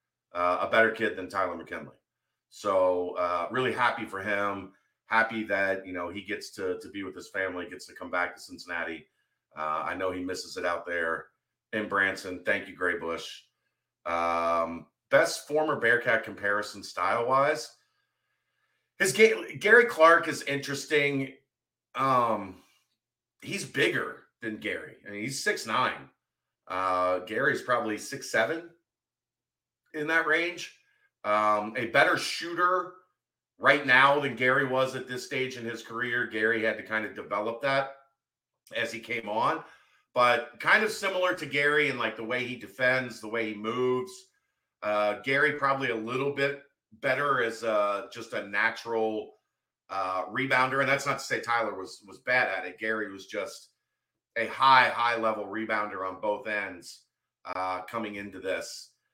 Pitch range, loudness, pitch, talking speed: 95-140 Hz, -28 LUFS, 115 Hz, 160 wpm